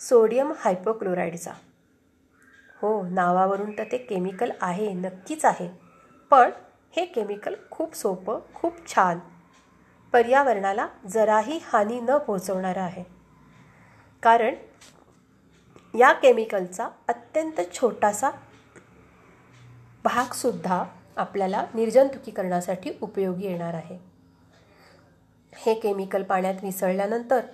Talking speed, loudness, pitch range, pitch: 85 wpm, -24 LUFS, 180-235 Hz, 200 Hz